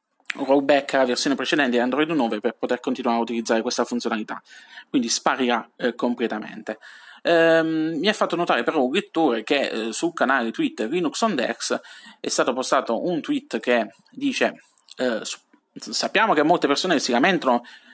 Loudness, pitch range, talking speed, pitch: -22 LUFS, 120-185 Hz, 155 wpm, 145 Hz